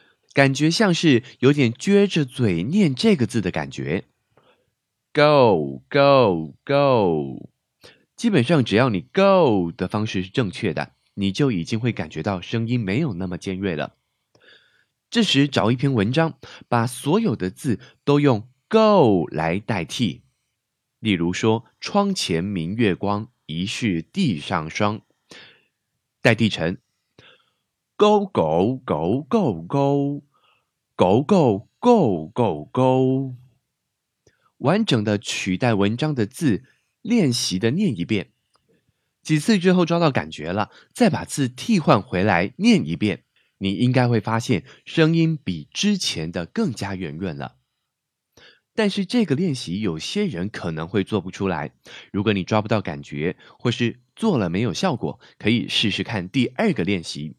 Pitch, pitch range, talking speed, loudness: 120 Hz, 95-155 Hz, 210 characters per minute, -21 LUFS